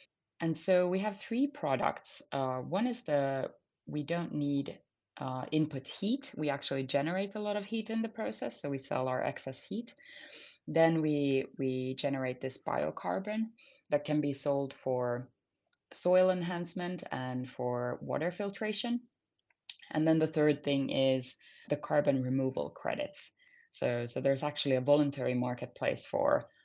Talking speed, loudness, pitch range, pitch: 150 wpm, -33 LUFS, 135-185 Hz, 145 Hz